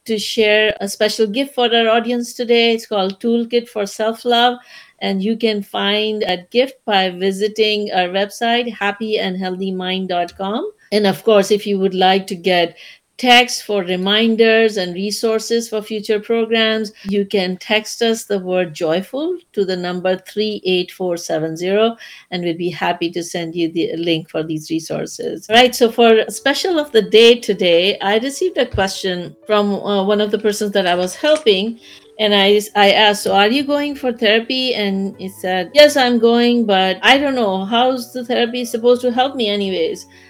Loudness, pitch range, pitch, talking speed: -16 LUFS, 190-235 Hz, 210 Hz, 175 wpm